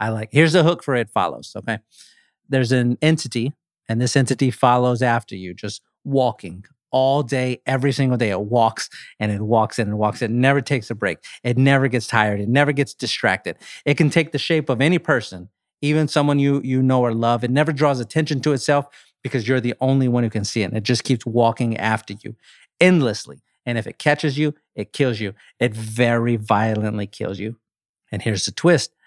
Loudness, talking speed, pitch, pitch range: -20 LUFS, 215 wpm, 125 Hz, 110-140 Hz